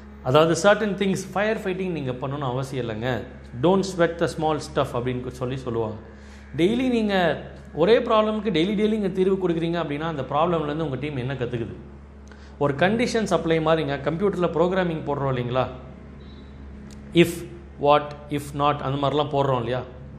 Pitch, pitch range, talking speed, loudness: 145 Hz, 125-175 Hz, 145 wpm, -23 LUFS